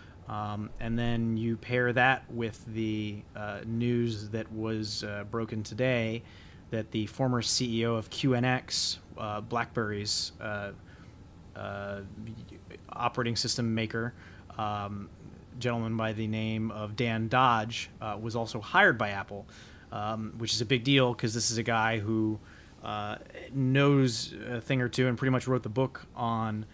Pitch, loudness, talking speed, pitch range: 110 Hz, -30 LUFS, 150 wpm, 105-120 Hz